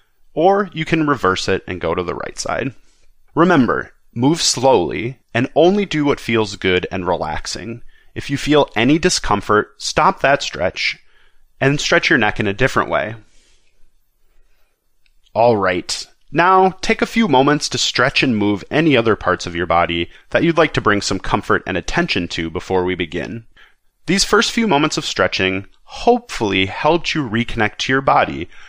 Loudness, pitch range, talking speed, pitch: -17 LUFS, 95-155 Hz, 170 wpm, 120 Hz